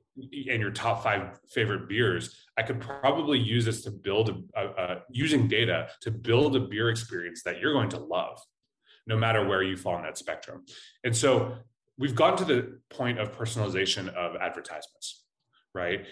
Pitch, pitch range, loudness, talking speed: 115 Hz, 105-125 Hz, -28 LUFS, 180 wpm